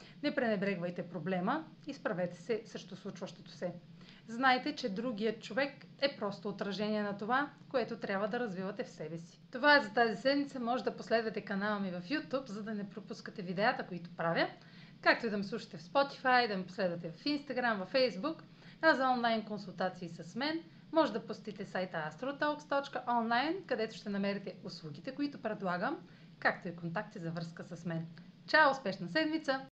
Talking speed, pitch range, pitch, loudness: 170 wpm, 185-255 Hz, 215 Hz, -35 LUFS